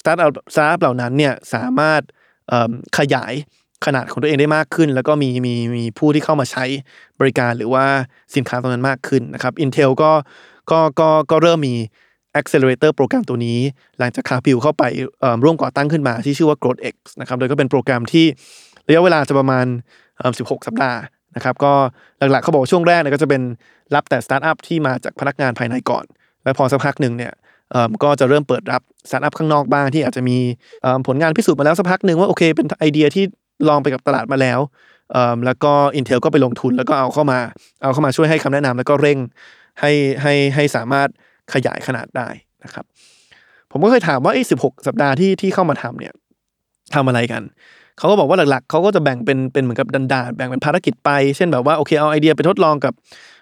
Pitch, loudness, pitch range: 140 Hz, -16 LUFS, 130-150 Hz